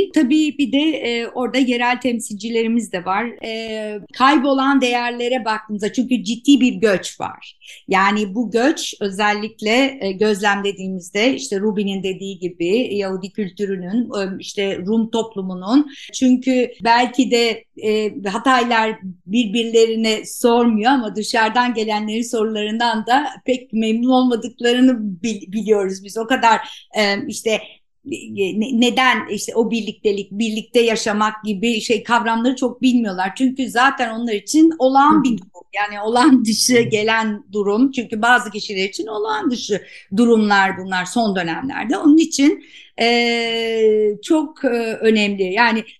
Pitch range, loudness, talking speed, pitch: 210-250 Hz, -18 LUFS, 125 wpm, 225 Hz